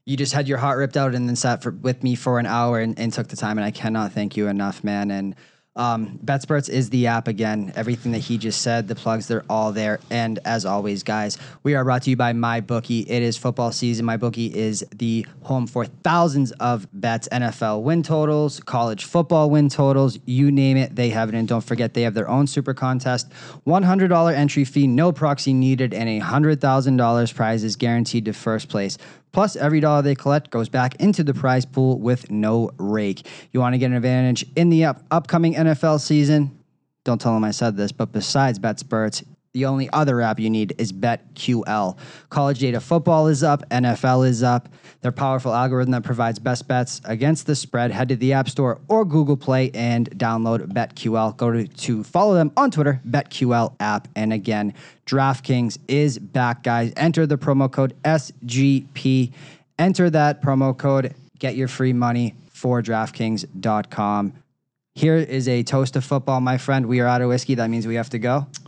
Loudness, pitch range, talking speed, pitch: -21 LUFS, 115-140 Hz, 200 wpm, 125 Hz